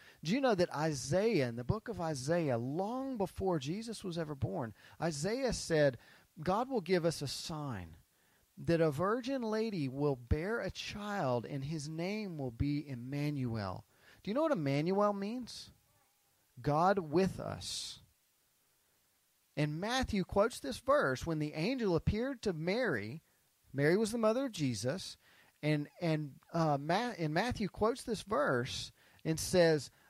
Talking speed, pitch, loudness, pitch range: 150 wpm, 165 Hz, -35 LUFS, 140-205 Hz